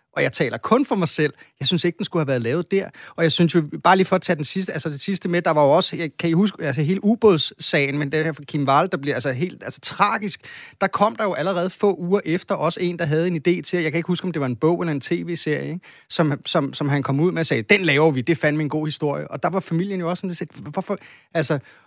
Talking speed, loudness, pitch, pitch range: 295 wpm, -21 LUFS, 170 Hz, 150-180 Hz